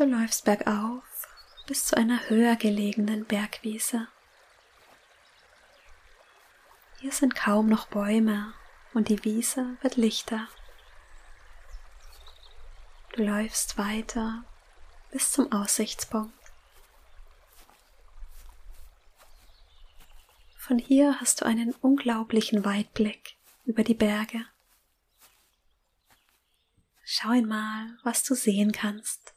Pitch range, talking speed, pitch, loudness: 210-235 Hz, 85 wpm, 220 Hz, -27 LUFS